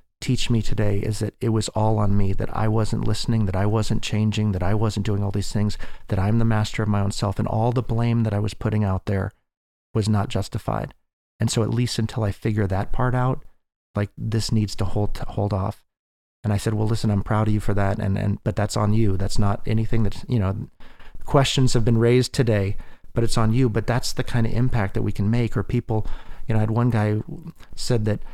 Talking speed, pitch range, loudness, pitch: 245 wpm, 105-115 Hz, -23 LUFS, 110 Hz